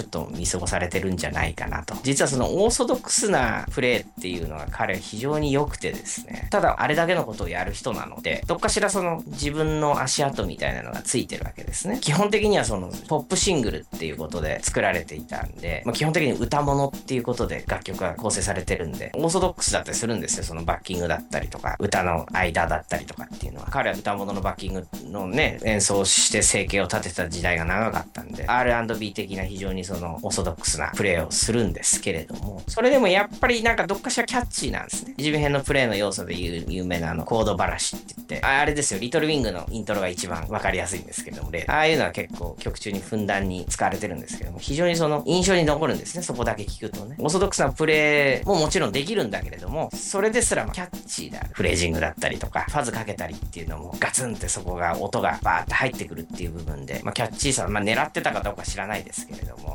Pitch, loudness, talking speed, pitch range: 105 Hz, -24 LUFS, 505 characters per minute, 90-150 Hz